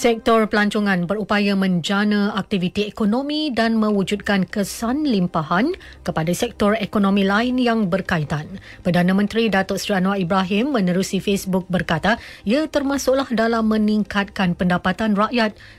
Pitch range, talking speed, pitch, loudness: 190-225 Hz, 120 wpm, 205 Hz, -20 LUFS